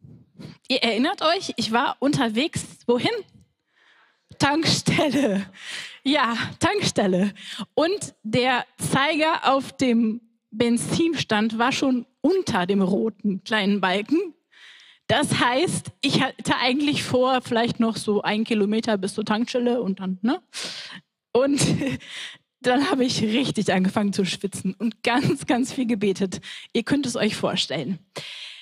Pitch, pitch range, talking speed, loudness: 235 Hz, 205-260 Hz, 120 wpm, -23 LUFS